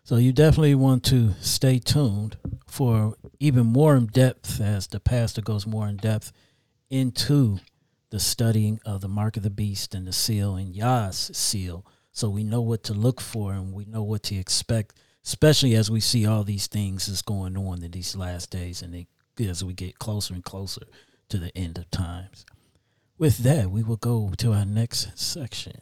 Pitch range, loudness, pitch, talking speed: 100-120 Hz, -24 LUFS, 110 Hz, 195 wpm